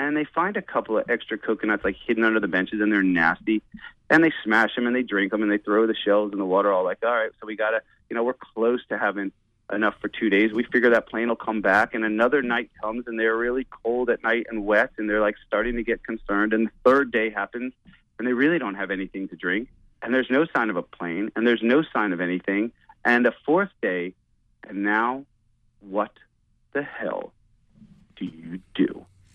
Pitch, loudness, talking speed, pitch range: 110 Hz, -23 LUFS, 235 wpm, 100-120 Hz